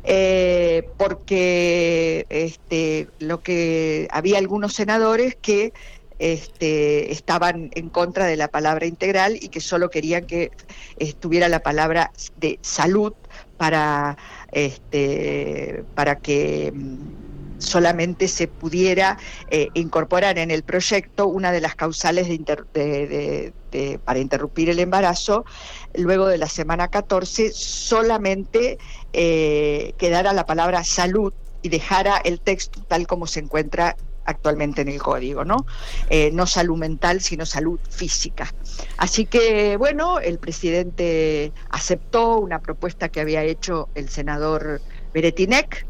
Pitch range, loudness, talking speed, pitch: 155-185 Hz, -21 LUFS, 130 wpm, 170 Hz